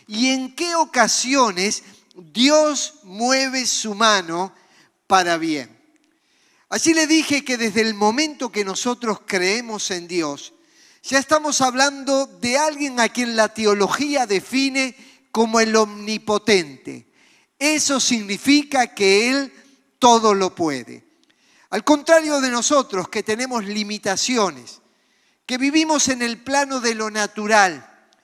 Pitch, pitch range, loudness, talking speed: 240 Hz, 210-280 Hz, -19 LUFS, 120 wpm